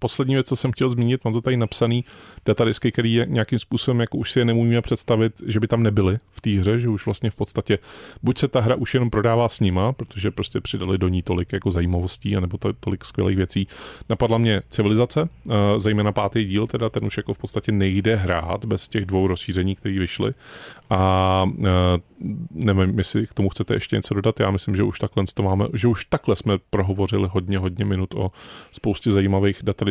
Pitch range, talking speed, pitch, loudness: 95-115 Hz, 210 wpm, 105 Hz, -22 LUFS